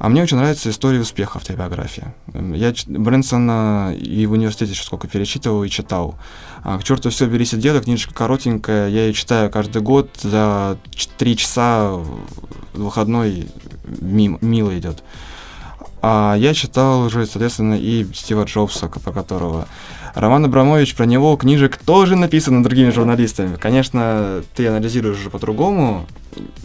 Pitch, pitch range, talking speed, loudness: 110 Hz, 100-125 Hz, 140 wpm, -17 LUFS